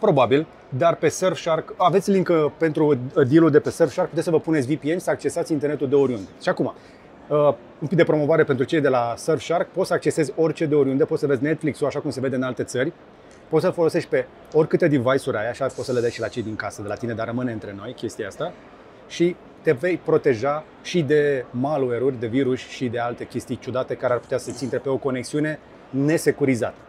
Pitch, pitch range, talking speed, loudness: 145 Hz, 130-160 Hz, 220 wpm, -22 LUFS